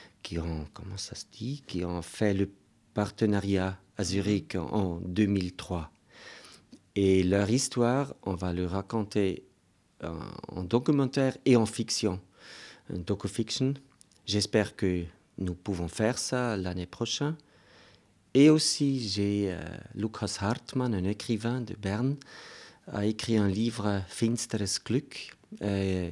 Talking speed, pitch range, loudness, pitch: 125 wpm, 95-115 Hz, -30 LUFS, 105 Hz